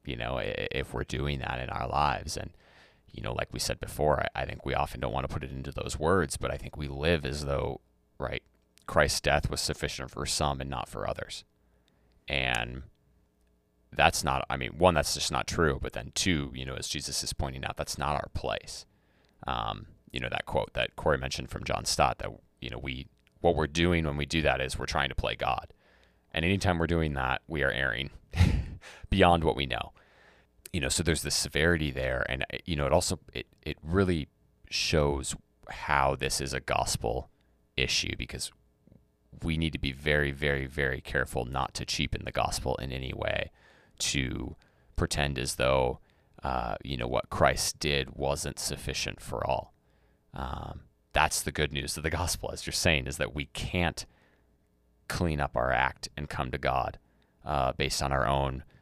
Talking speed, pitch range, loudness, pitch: 195 wpm, 65-75 Hz, -30 LUFS, 70 Hz